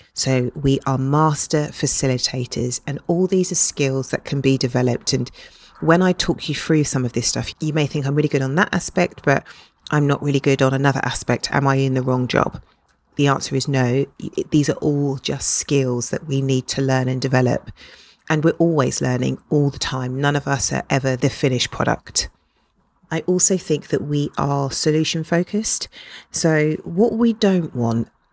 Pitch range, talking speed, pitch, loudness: 130-155 Hz, 195 wpm, 140 Hz, -19 LUFS